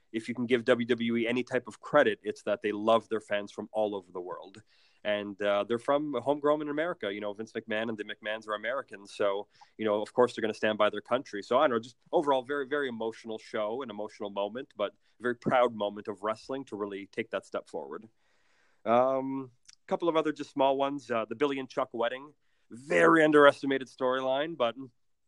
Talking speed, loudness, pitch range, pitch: 220 wpm, -30 LUFS, 105-135 Hz, 120 Hz